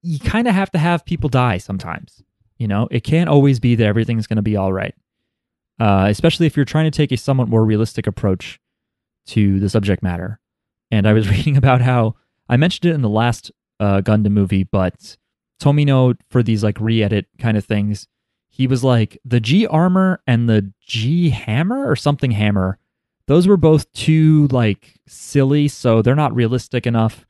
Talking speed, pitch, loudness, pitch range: 190 wpm, 120 Hz, -17 LUFS, 105-145 Hz